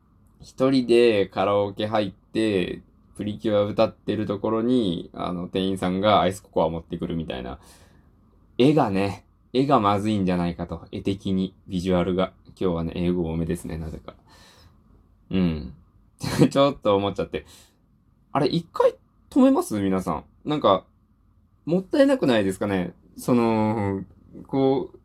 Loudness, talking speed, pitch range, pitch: -24 LUFS, 300 characters per minute, 90-110 Hz, 100 Hz